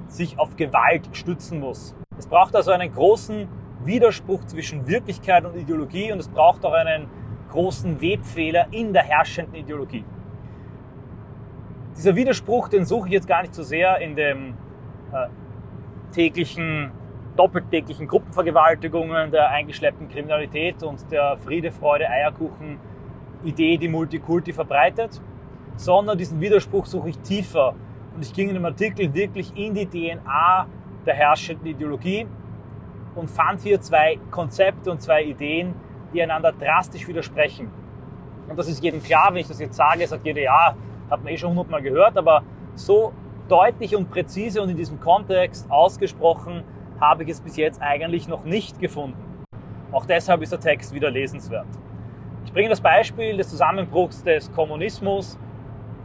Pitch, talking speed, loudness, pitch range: 160 Hz, 150 wpm, -21 LUFS, 140-180 Hz